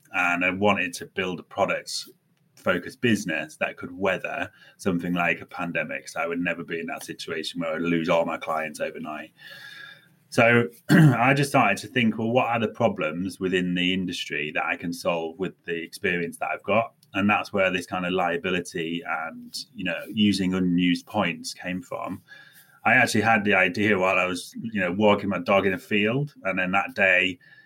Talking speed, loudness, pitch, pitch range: 195 wpm, -24 LUFS, 95 Hz, 90-115 Hz